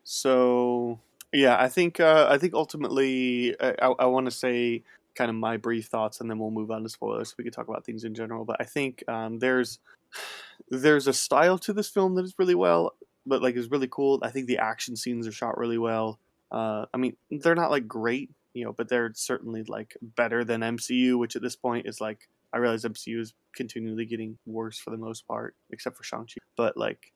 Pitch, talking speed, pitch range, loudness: 120 Hz, 225 wpm, 115-130 Hz, -27 LUFS